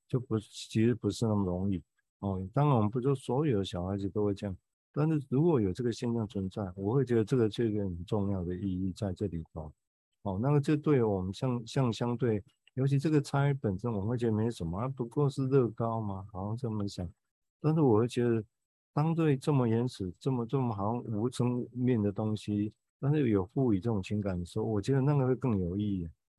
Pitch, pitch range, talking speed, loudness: 115 Hz, 100-130 Hz, 320 characters per minute, -31 LUFS